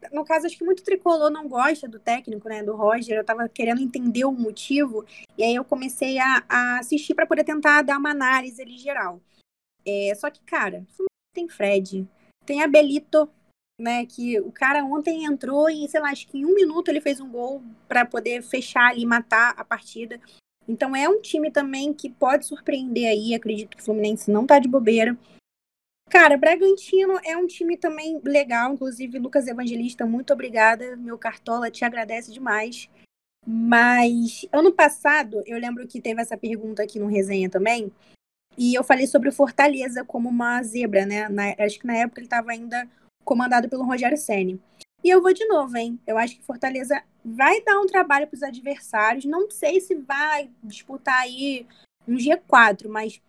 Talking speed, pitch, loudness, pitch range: 180 wpm, 250 Hz, -21 LUFS, 225-290 Hz